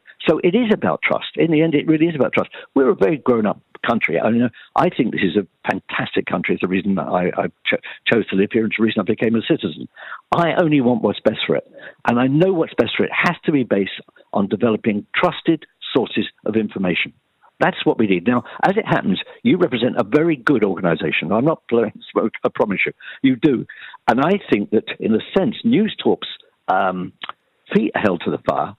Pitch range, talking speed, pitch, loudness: 110-170 Hz, 225 wpm, 125 Hz, -19 LUFS